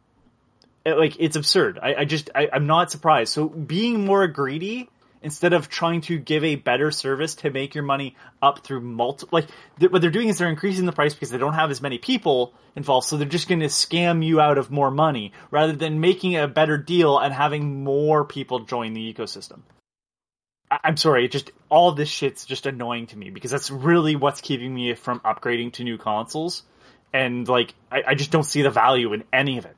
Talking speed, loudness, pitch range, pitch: 210 wpm, -22 LUFS, 130-160 Hz, 145 Hz